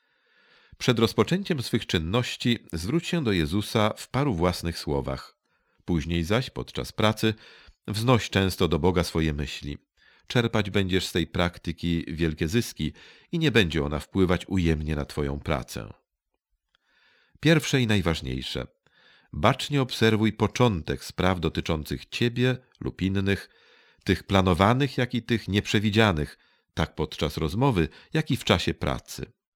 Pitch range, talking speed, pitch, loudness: 85-120 Hz, 130 wpm, 95 Hz, -26 LUFS